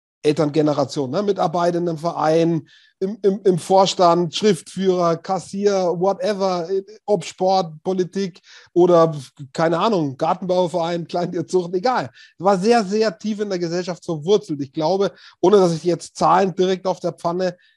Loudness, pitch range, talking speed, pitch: -20 LUFS, 165-195 Hz, 140 wpm, 180 Hz